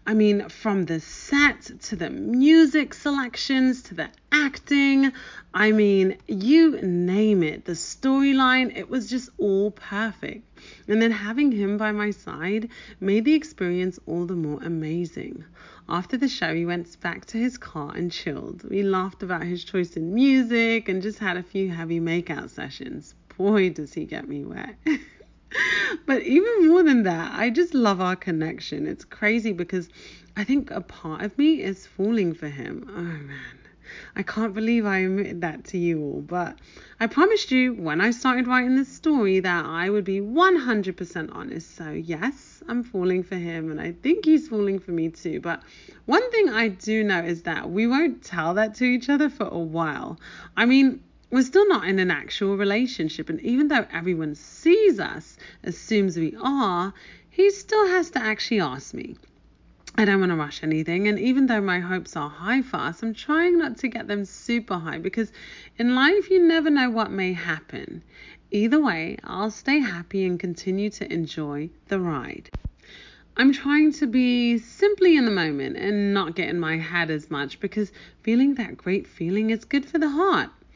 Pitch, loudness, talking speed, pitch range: 210 Hz, -23 LUFS, 185 wpm, 175-260 Hz